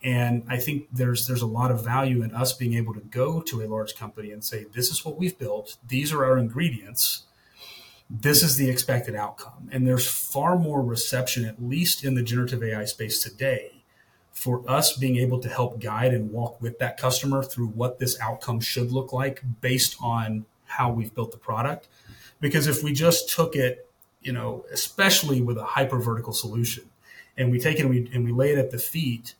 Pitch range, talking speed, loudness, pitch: 115-135 Hz, 205 wpm, -25 LUFS, 125 Hz